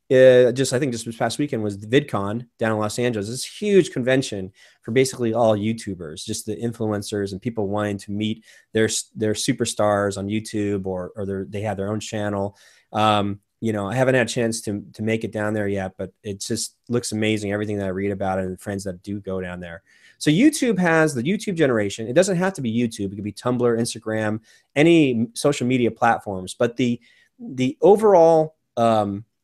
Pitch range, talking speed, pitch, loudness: 100-125 Hz, 210 wpm, 110 Hz, -22 LUFS